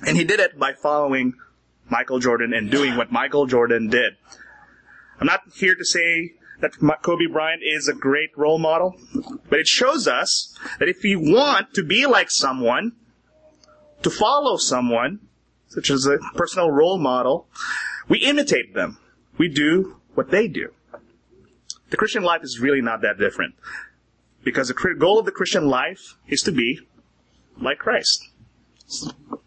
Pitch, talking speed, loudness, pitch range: 155 Hz, 155 wpm, -20 LUFS, 135-190 Hz